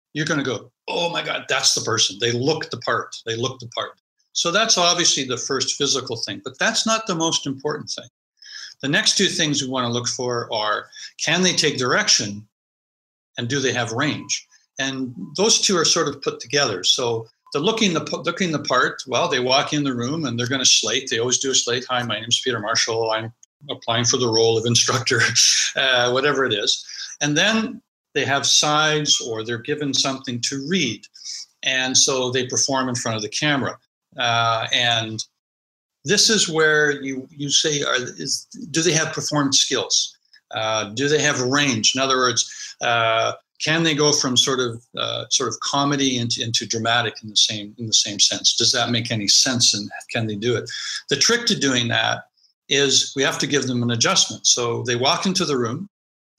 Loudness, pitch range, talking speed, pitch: -19 LUFS, 120-155 Hz, 205 wpm, 135 Hz